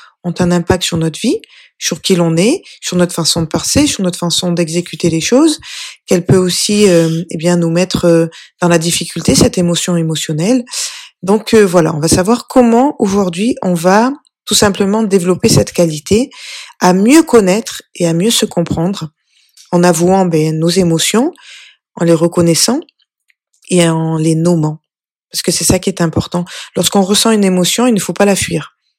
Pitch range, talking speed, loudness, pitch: 170-215 Hz, 180 wpm, -12 LUFS, 180 Hz